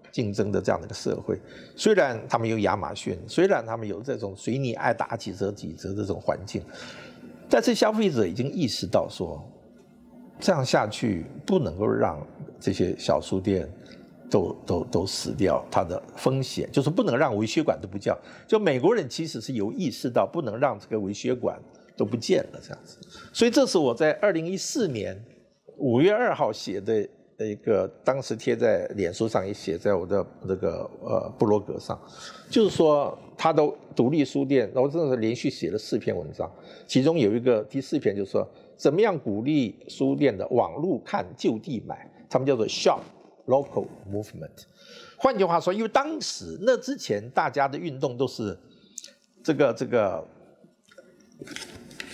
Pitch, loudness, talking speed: 145 Hz, -26 LUFS, 270 characters per minute